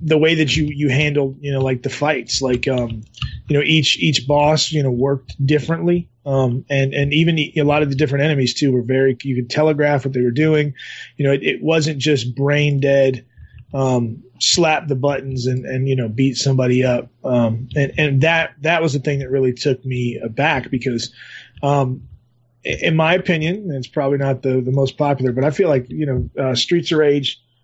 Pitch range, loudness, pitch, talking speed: 130-150 Hz, -18 LUFS, 140 Hz, 215 wpm